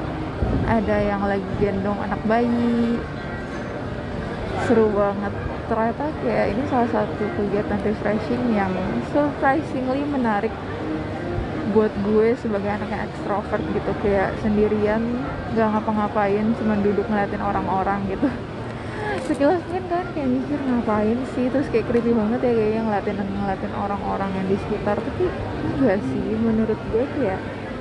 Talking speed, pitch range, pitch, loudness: 125 wpm, 205-240 Hz, 220 Hz, -23 LUFS